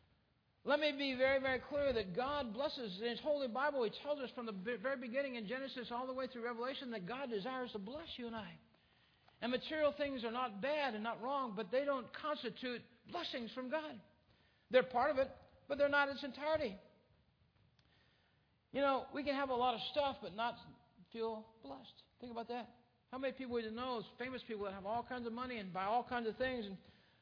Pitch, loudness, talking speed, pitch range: 255 Hz, -40 LUFS, 215 wpm, 235-275 Hz